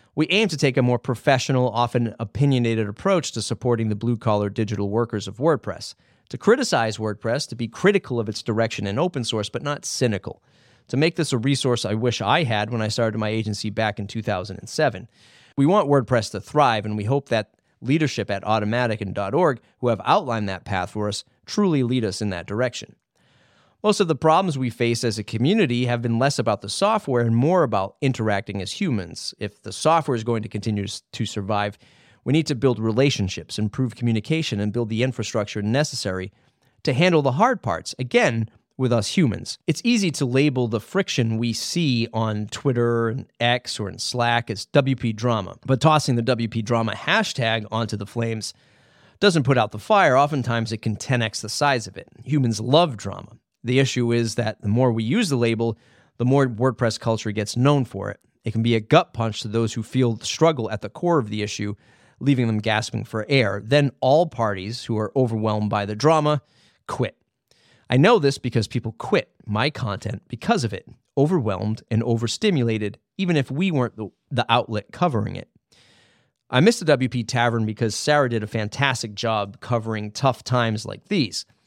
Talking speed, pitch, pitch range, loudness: 190 wpm, 120 Hz, 110-135 Hz, -22 LUFS